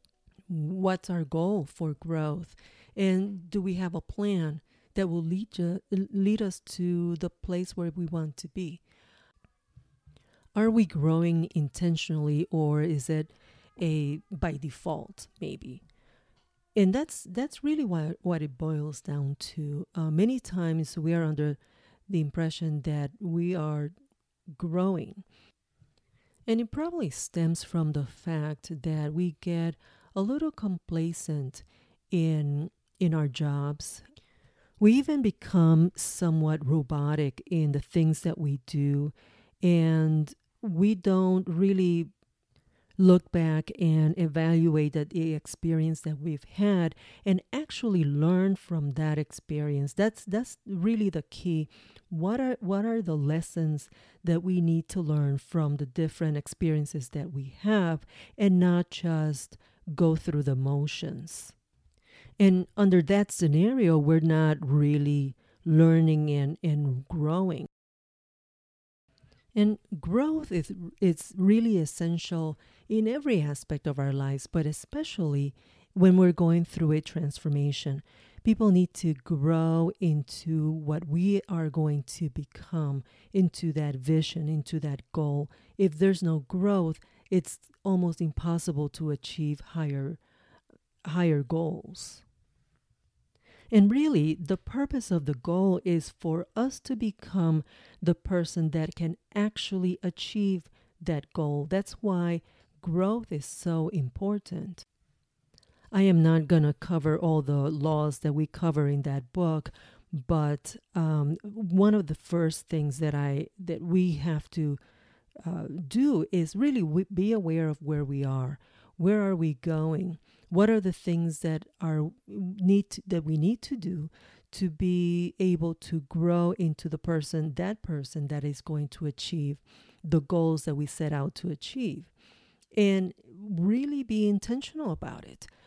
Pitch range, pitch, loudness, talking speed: 150-185 Hz, 165 Hz, -28 LUFS, 135 wpm